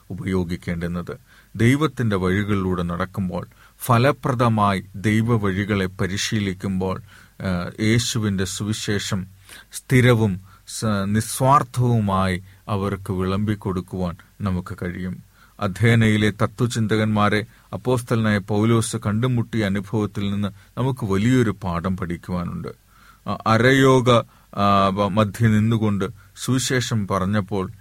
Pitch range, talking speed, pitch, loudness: 95-115 Hz, 70 wpm, 105 Hz, -21 LUFS